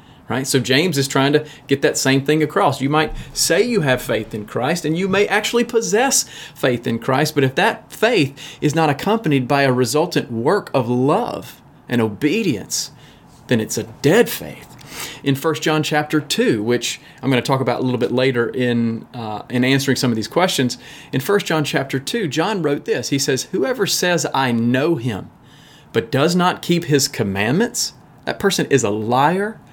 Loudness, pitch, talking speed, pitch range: -18 LUFS, 140 Hz, 195 wpm, 125-155 Hz